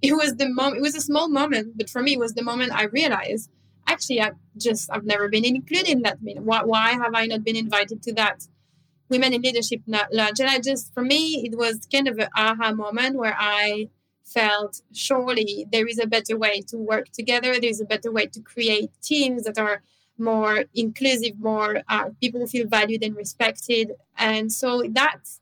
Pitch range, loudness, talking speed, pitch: 215-250 Hz, -22 LUFS, 205 wpm, 225 Hz